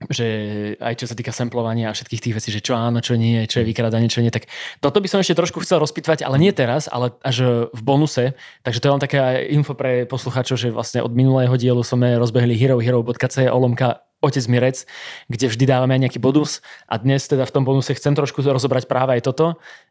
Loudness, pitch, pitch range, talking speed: -19 LUFS, 130 Hz, 120-140 Hz, 215 wpm